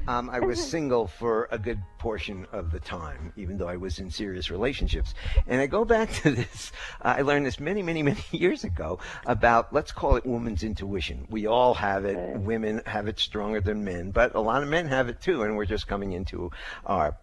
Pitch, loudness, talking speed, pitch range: 105 Hz, -27 LUFS, 220 wpm, 95-120 Hz